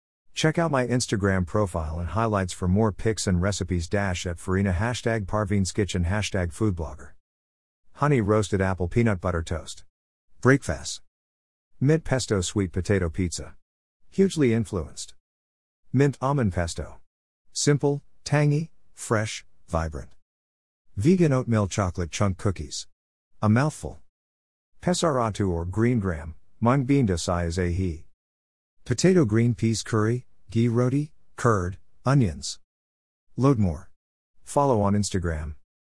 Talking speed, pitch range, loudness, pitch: 120 wpm, 80-115 Hz, -25 LUFS, 95 Hz